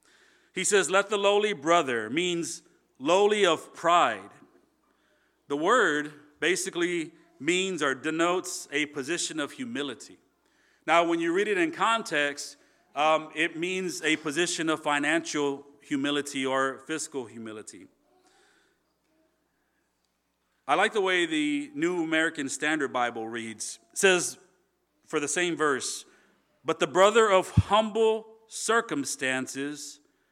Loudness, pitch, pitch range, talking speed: -26 LUFS, 170 Hz, 145-210 Hz, 120 wpm